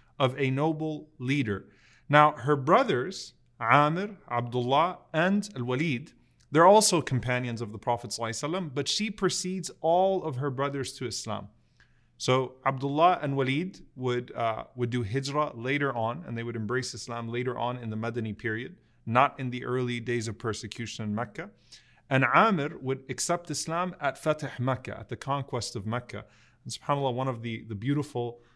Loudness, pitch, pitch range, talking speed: -28 LUFS, 130 Hz, 120-145 Hz, 165 wpm